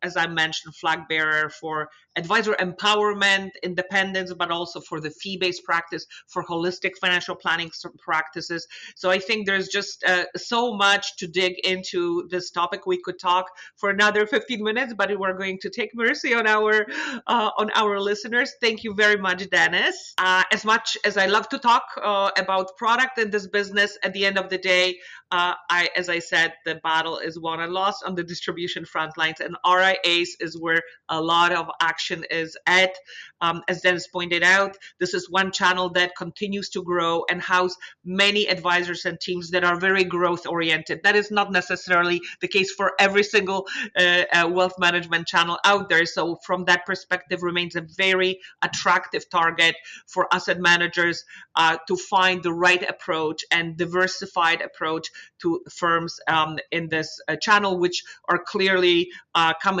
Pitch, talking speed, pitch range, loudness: 180 Hz, 180 wpm, 170-195 Hz, -22 LUFS